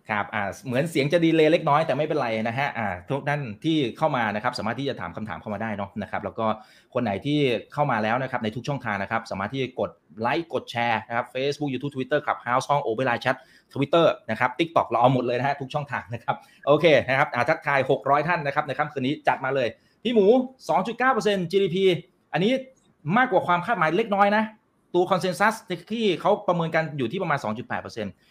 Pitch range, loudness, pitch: 120-175 Hz, -24 LUFS, 140 Hz